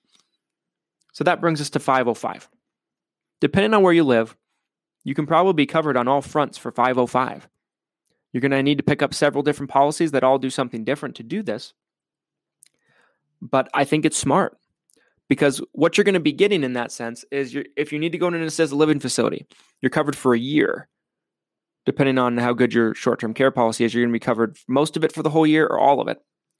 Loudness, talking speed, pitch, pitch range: -20 LUFS, 220 wpm, 140 Hz, 125-155 Hz